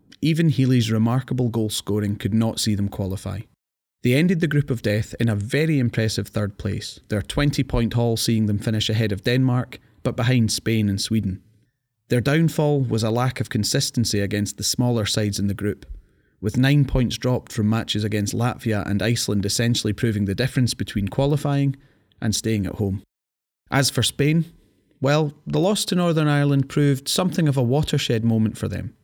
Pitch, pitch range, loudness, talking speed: 115 Hz, 105-135 Hz, -22 LUFS, 180 wpm